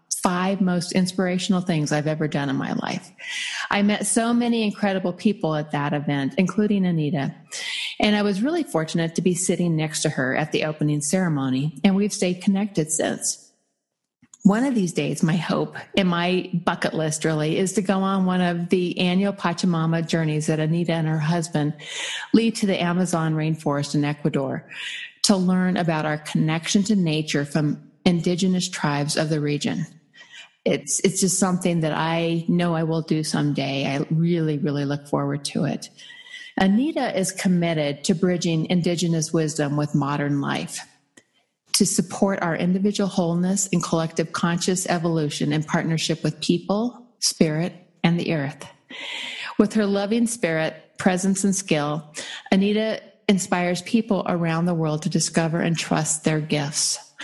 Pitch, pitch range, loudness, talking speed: 175 Hz, 155-195 Hz, -23 LUFS, 160 wpm